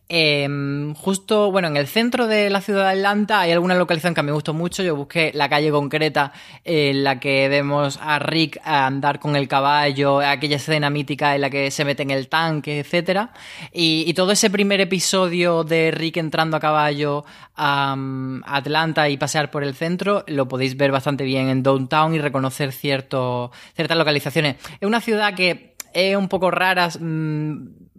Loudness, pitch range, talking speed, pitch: -19 LUFS, 140-175 Hz, 180 wpm, 150 Hz